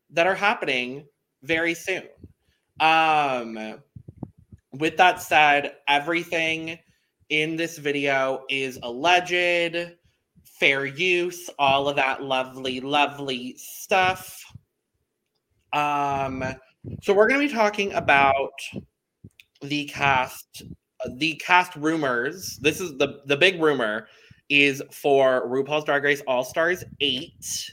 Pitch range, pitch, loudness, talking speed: 135-170 Hz, 145 Hz, -22 LUFS, 110 wpm